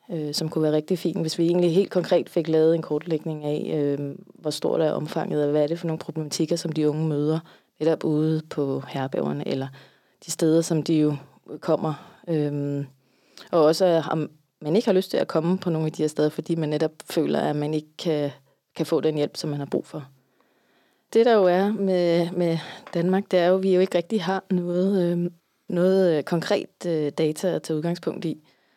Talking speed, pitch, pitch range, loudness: 215 wpm, 160 Hz, 150-175 Hz, -24 LUFS